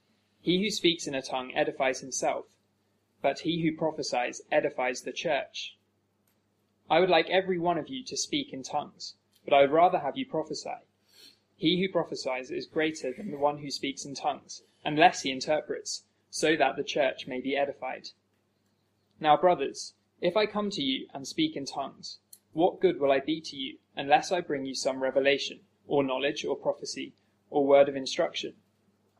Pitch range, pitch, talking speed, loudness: 130-175 Hz, 140 Hz, 180 wpm, -29 LUFS